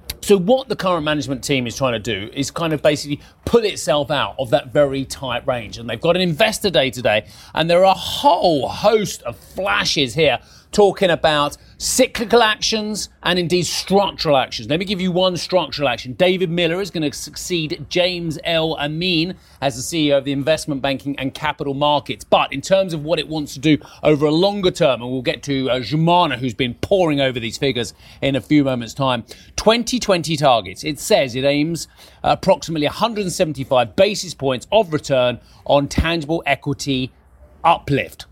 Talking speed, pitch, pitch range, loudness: 185 wpm, 150 Hz, 135-180 Hz, -18 LUFS